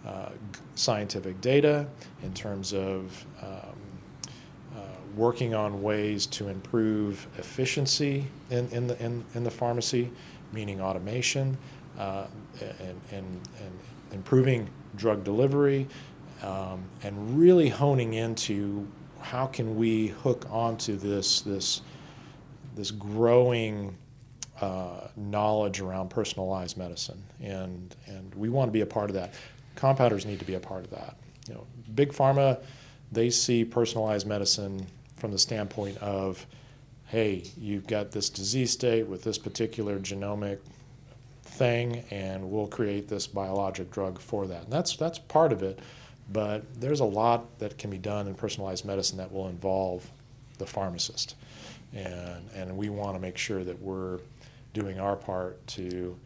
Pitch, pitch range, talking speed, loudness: 110 Hz, 100-125 Hz, 145 wpm, -29 LUFS